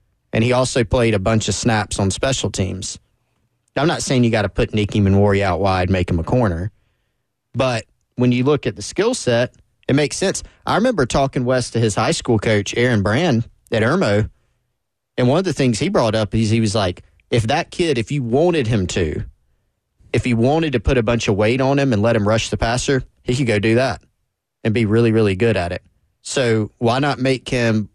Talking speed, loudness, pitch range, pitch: 225 wpm, -18 LUFS, 105-125 Hz, 115 Hz